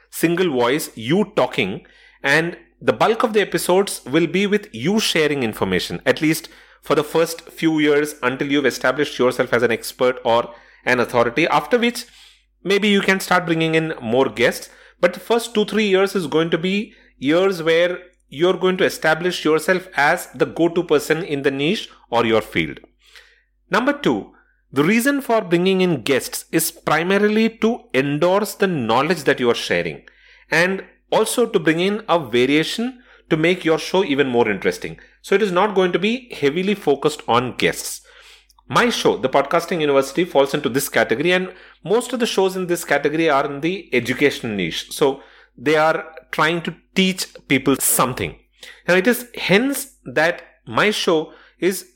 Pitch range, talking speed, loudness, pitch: 145-195 Hz, 175 wpm, -19 LUFS, 170 Hz